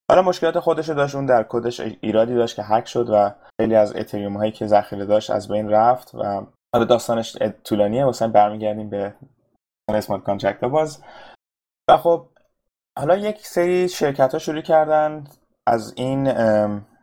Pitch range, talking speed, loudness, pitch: 105-145 Hz, 155 wpm, -20 LUFS, 115 Hz